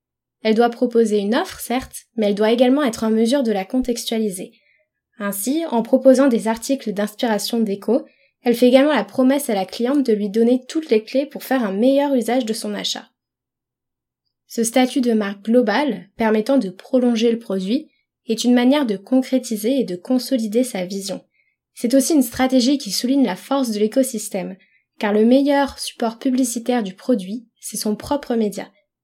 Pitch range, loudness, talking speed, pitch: 215-260 Hz, -19 LUFS, 180 wpm, 240 Hz